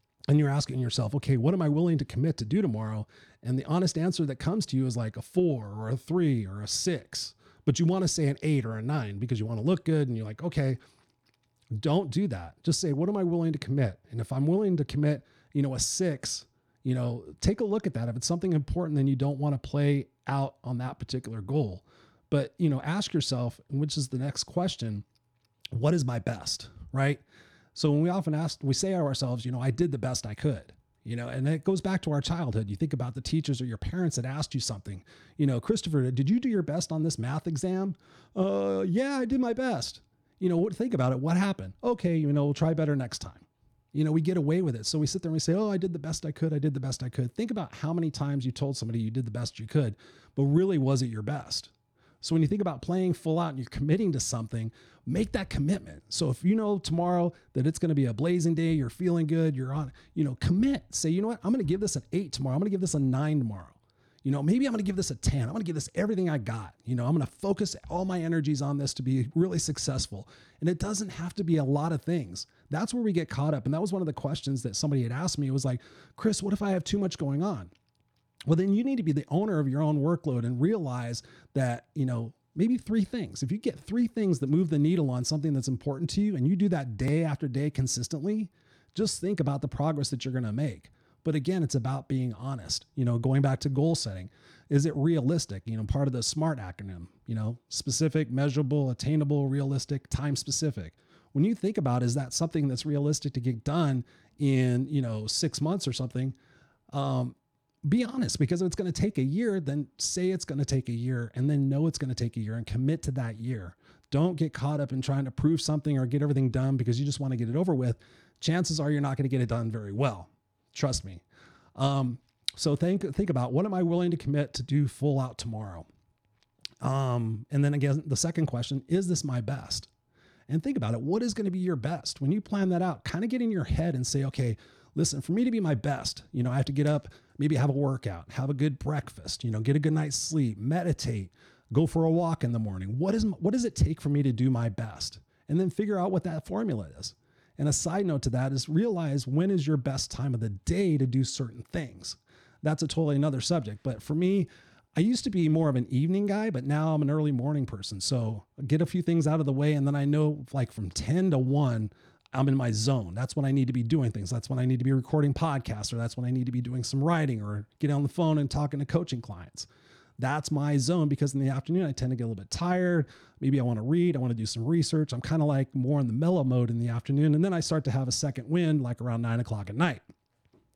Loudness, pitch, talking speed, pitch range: -29 LUFS, 145 Hz, 265 wpm, 125-165 Hz